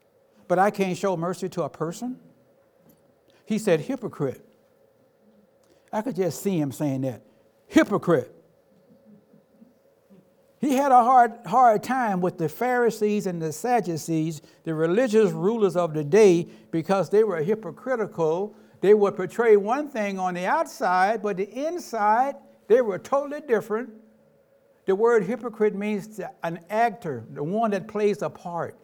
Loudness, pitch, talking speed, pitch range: -24 LUFS, 210 Hz, 140 wpm, 180-245 Hz